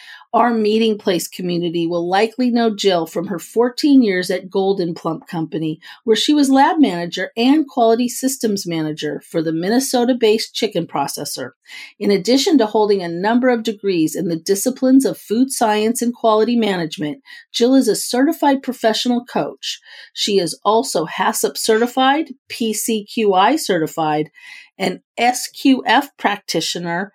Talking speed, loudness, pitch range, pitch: 140 wpm, -17 LUFS, 180-250 Hz, 220 Hz